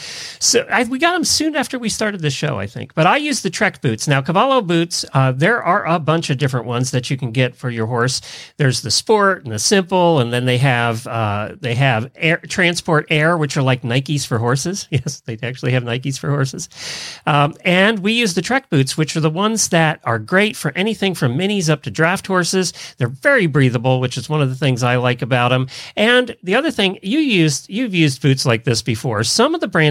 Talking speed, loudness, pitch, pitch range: 235 wpm, -17 LUFS, 150 Hz, 130-190 Hz